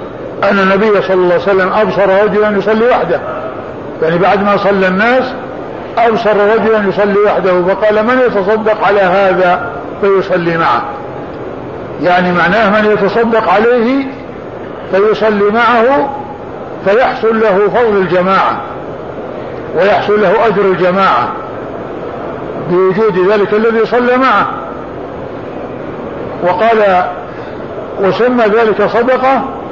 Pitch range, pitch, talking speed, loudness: 190-225 Hz, 210 Hz, 100 wpm, -10 LUFS